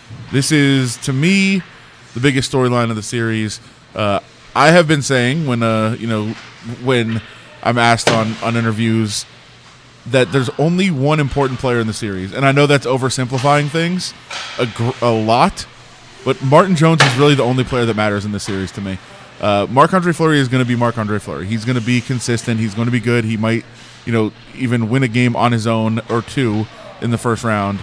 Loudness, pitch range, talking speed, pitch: -16 LUFS, 115-135 Hz, 205 wpm, 120 Hz